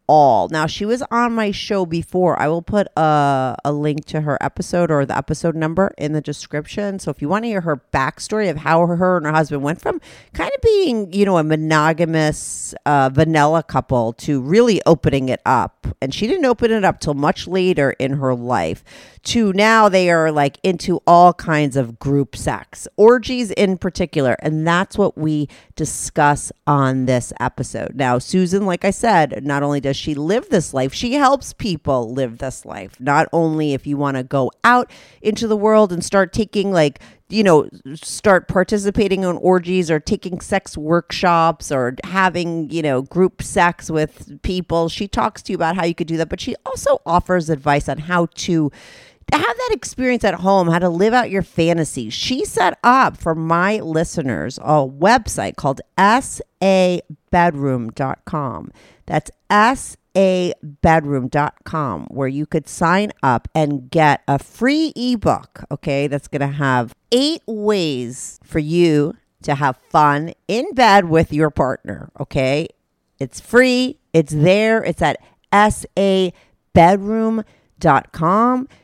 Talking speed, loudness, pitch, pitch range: 165 wpm, -17 LUFS, 165 Hz, 145-195 Hz